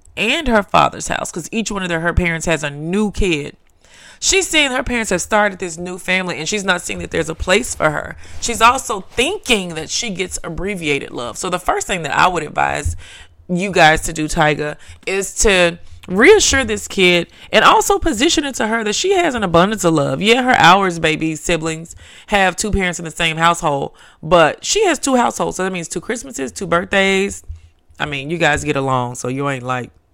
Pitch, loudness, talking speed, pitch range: 180 Hz, -16 LUFS, 215 wpm, 155-215 Hz